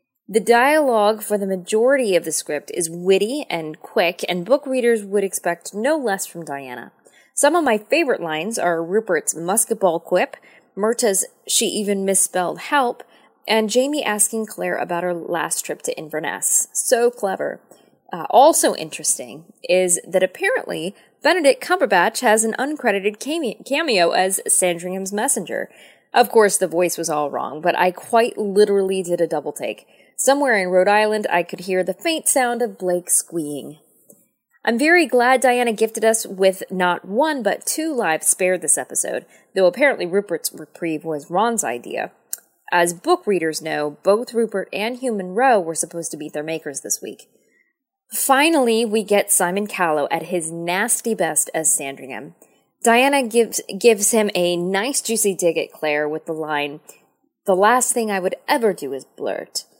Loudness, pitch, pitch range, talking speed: -19 LUFS, 200 Hz, 175-240 Hz, 165 wpm